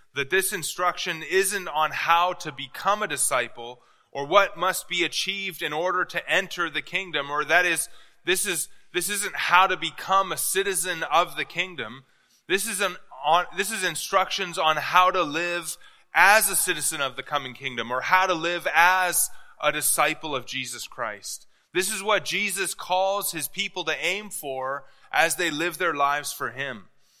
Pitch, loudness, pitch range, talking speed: 180 Hz, -24 LUFS, 150-190 Hz, 180 wpm